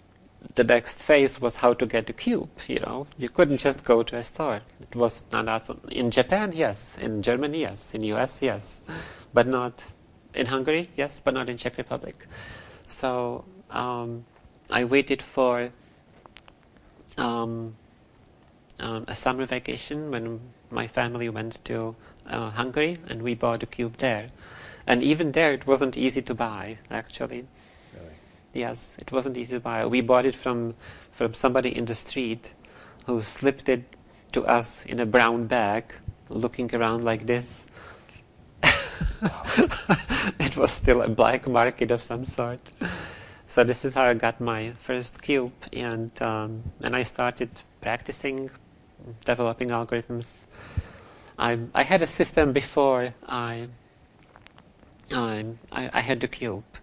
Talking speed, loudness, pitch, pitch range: 145 wpm, -26 LUFS, 120 Hz, 115-130 Hz